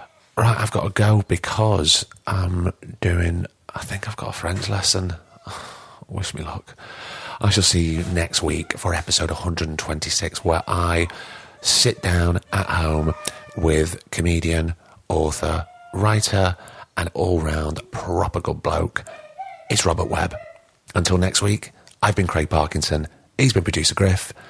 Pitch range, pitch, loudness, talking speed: 85-105 Hz, 90 Hz, -21 LUFS, 135 wpm